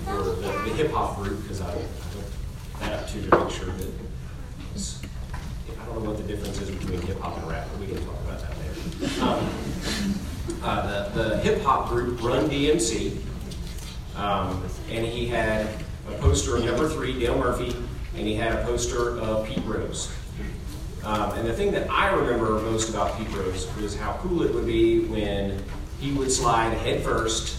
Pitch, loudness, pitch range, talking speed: 100 Hz, -27 LUFS, 90-115 Hz, 180 wpm